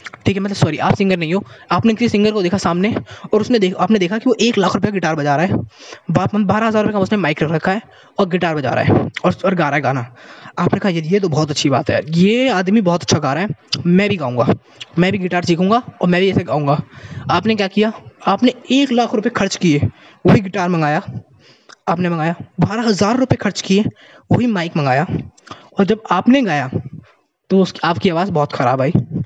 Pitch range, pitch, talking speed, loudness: 160-210 Hz, 185 Hz, 225 wpm, -16 LUFS